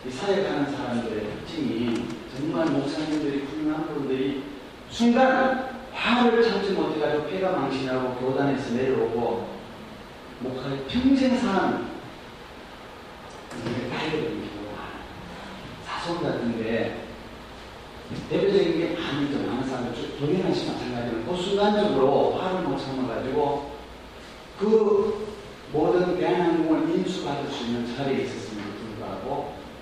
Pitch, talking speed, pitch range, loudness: 150 Hz, 285 characters per minute, 125-205 Hz, -26 LUFS